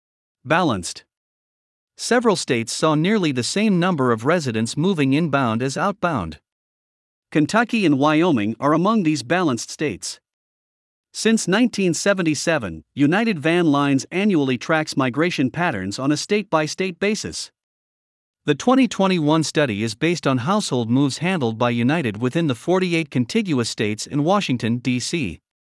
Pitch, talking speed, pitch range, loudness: 155 Hz, 130 wpm, 125-185 Hz, -20 LUFS